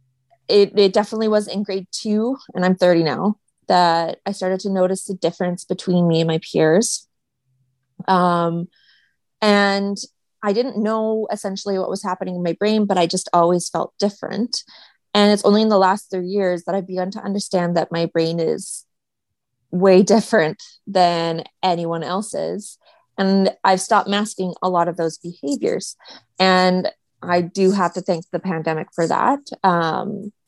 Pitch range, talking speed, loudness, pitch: 170-205 Hz, 165 wpm, -19 LUFS, 185 Hz